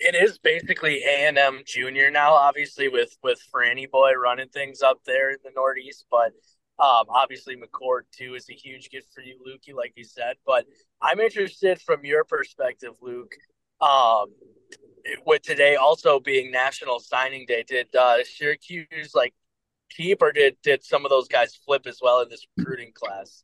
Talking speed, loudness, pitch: 175 wpm, -22 LUFS, 145 Hz